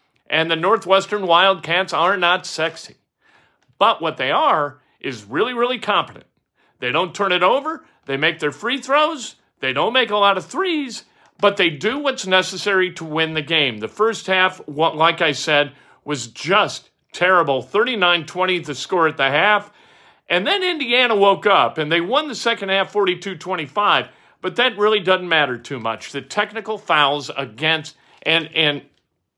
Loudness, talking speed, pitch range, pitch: -18 LUFS, 170 wpm, 160-210 Hz, 185 Hz